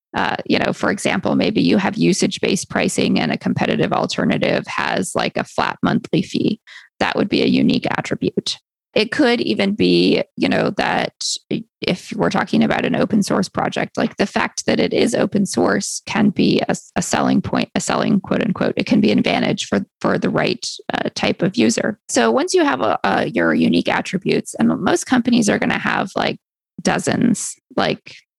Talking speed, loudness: 185 wpm, -18 LUFS